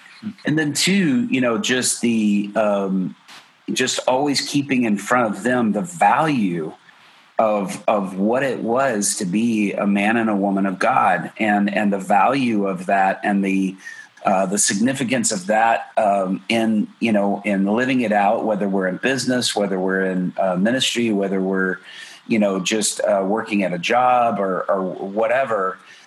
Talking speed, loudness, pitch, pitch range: 170 wpm, -19 LUFS, 105 Hz, 100-120 Hz